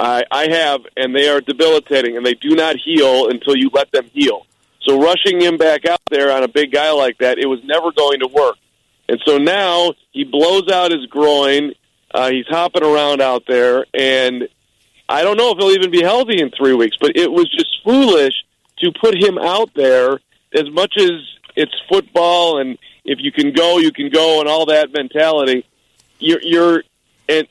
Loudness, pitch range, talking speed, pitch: -14 LUFS, 135-185 Hz, 195 wpm, 155 Hz